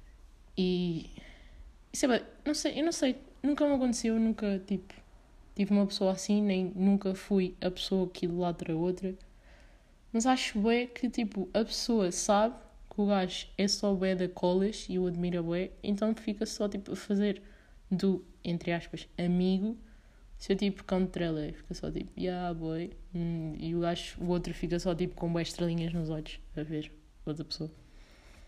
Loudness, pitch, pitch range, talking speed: -32 LUFS, 185 Hz, 175-210 Hz, 175 wpm